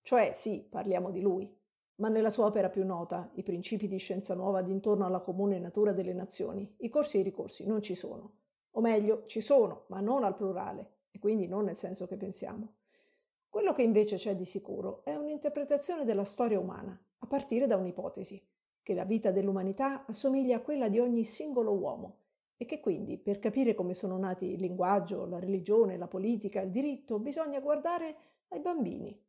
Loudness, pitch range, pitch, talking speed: -33 LUFS, 190-245 Hz, 205 Hz, 185 wpm